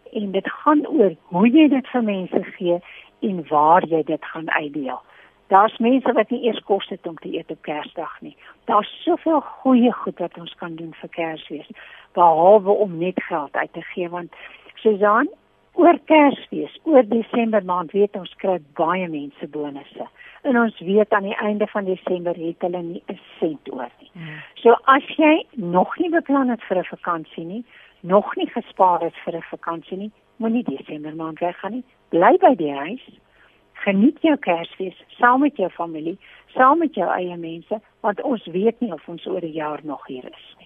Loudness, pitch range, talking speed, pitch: -20 LUFS, 175-245 Hz, 185 wpm, 200 Hz